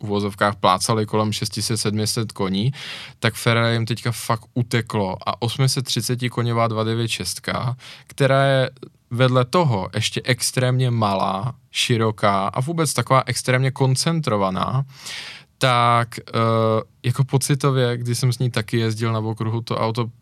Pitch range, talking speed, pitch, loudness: 110-130 Hz, 125 wpm, 120 Hz, -21 LUFS